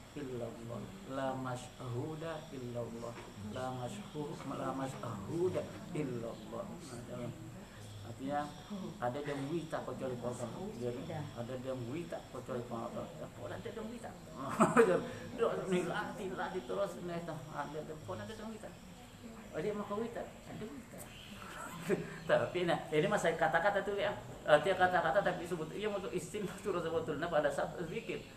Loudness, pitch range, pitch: -38 LUFS, 125-180 Hz, 150 Hz